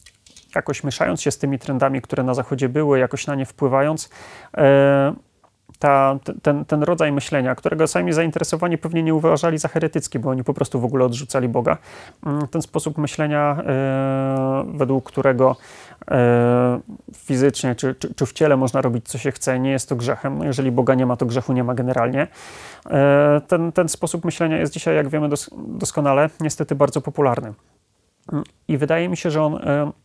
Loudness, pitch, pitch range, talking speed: -20 LUFS, 140 Hz, 130-155 Hz, 165 wpm